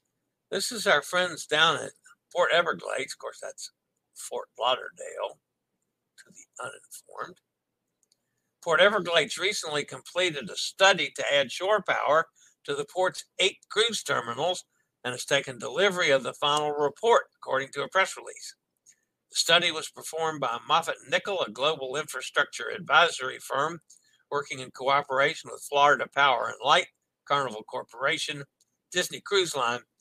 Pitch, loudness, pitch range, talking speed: 180 Hz, -26 LUFS, 145-230 Hz, 140 wpm